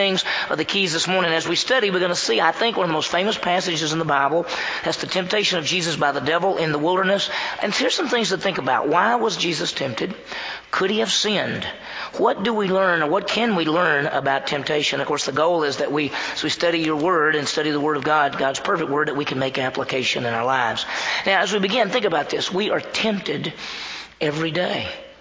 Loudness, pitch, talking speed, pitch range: -21 LUFS, 170 Hz, 240 wpm, 150-195 Hz